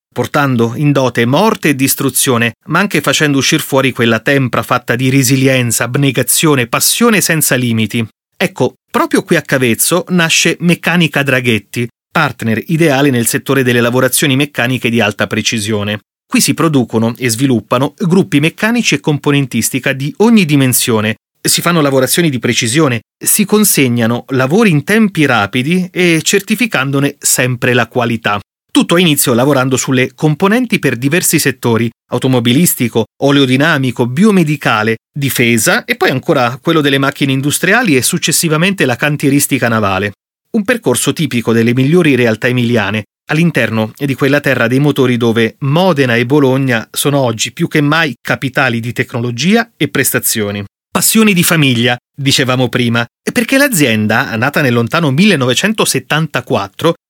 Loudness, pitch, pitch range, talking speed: -11 LUFS, 135 Hz, 120-160 Hz, 135 wpm